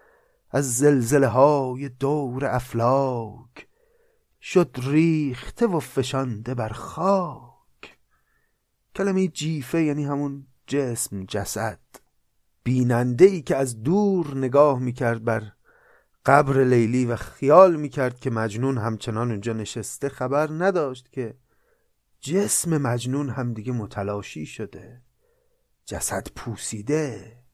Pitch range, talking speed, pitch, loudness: 120-150 Hz, 100 wpm, 135 Hz, -23 LUFS